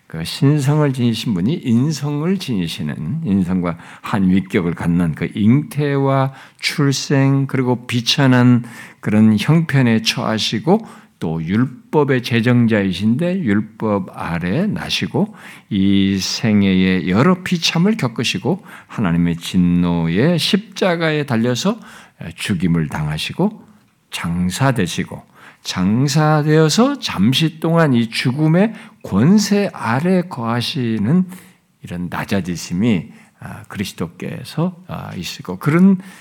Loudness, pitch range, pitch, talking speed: -17 LUFS, 105-175 Hz, 135 Hz, 235 characters per minute